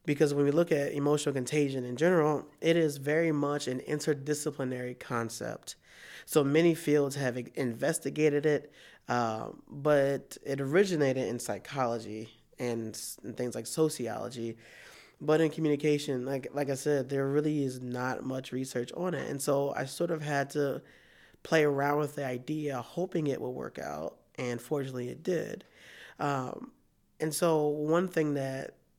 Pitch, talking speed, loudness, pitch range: 140 Hz, 155 wpm, -31 LUFS, 125-150 Hz